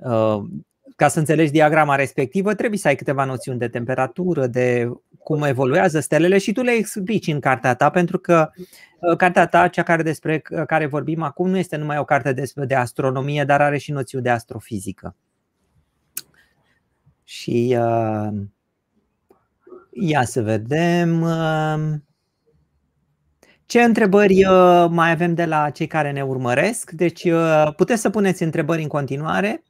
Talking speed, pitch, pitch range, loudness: 135 wpm, 155 Hz, 130-175 Hz, -19 LUFS